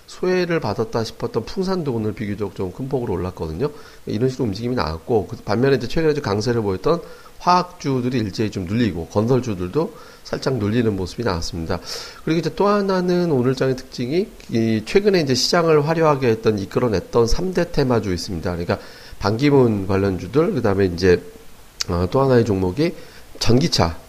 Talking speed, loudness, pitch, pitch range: 385 characters per minute, -20 LUFS, 115 Hz, 100-145 Hz